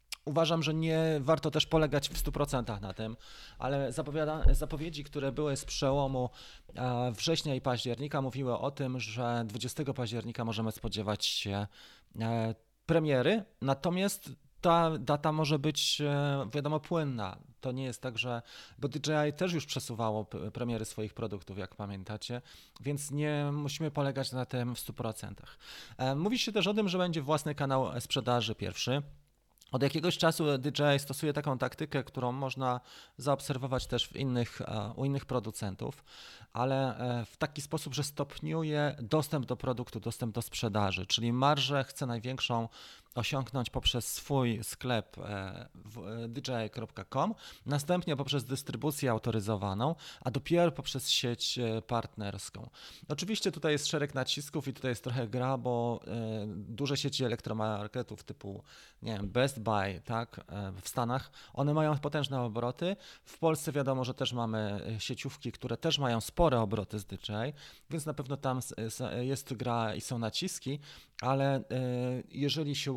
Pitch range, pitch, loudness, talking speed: 115-145 Hz, 130 Hz, -33 LUFS, 140 wpm